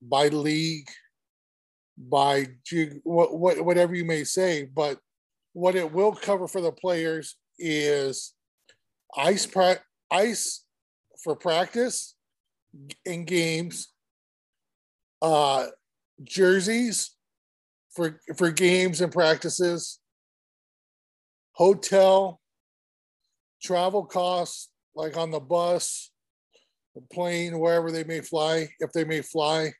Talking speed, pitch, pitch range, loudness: 95 wpm, 165 Hz, 145-180 Hz, -25 LUFS